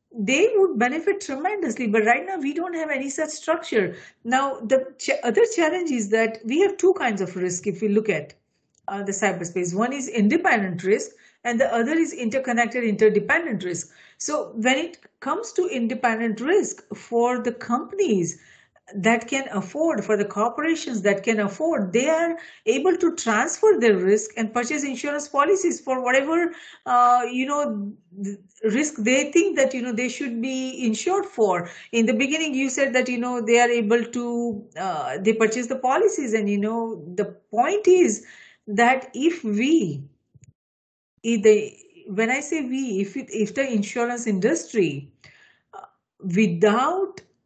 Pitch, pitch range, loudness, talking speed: 245 Hz, 215-310 Hz, -22 LUFS, 165 wpm